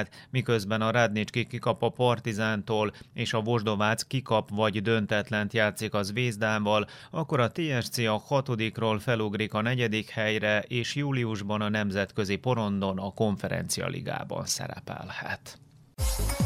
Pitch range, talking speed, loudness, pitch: 105-120 Hz, 120 wpm, -28 LUFS, 110 Hz